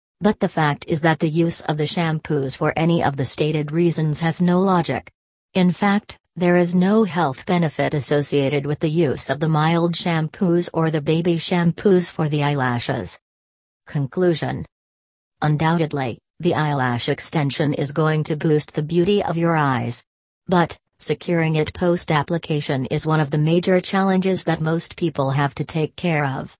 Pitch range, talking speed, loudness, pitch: 145-175 Hz, 165 wpm, -20 LUFS, 160 Hz